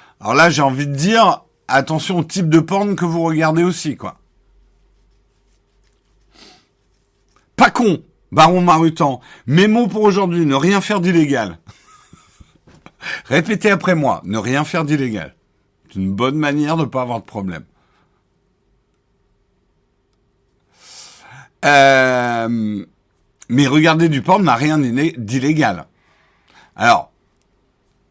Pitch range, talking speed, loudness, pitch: 130-175 Hz, 115 wpm, -15 LUFS, 155 Hz